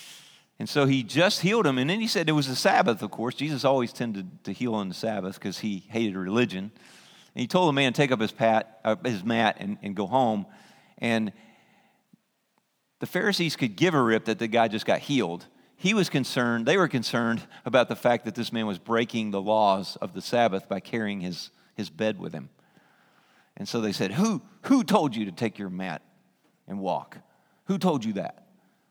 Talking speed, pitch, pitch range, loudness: 205 wpm, 120 Hz, 110-145 Hz, -26 LUFS